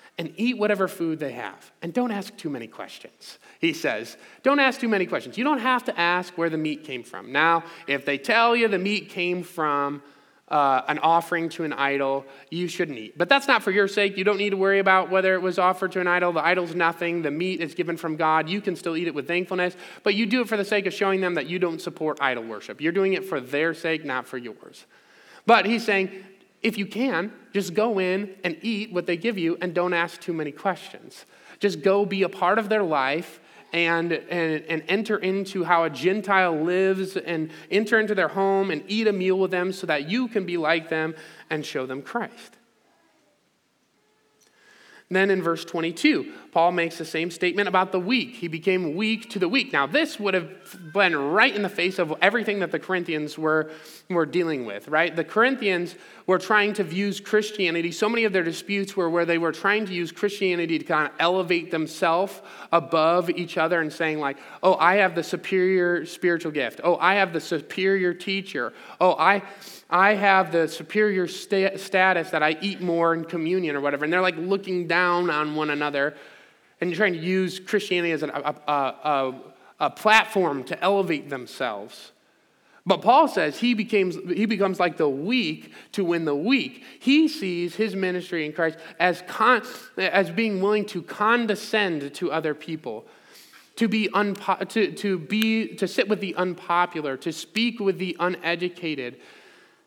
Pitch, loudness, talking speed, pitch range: 180 Hz, -24 LUFS, 200 wpm, 165-200 Hz